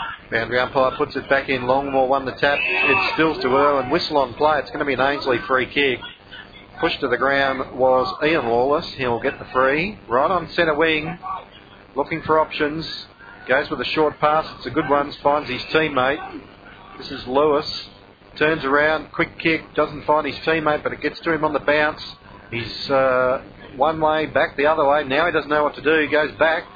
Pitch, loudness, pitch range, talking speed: 145 Hz, -20 LUFS, 130-155 Hz, 210 wpm